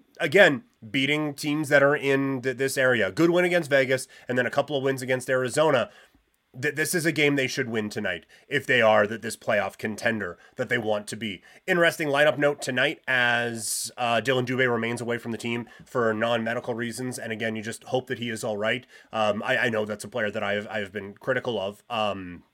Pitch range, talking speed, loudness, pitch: 110-135 Hz, 225 wpm, -25 LUFS, 125 Hz